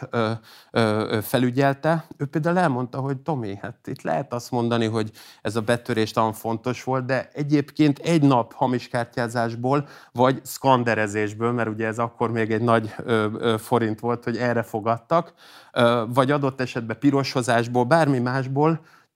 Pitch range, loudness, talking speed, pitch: 115-135 Hz, -23 LUFS, 140 wpm, 120 Hz